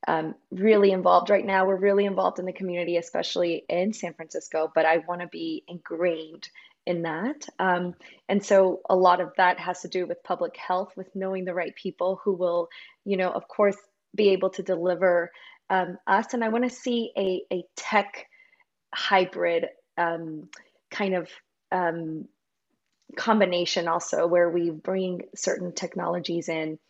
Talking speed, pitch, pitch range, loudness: 165 wpm, 185 Hz, 175-200 Hz, -26 LUFS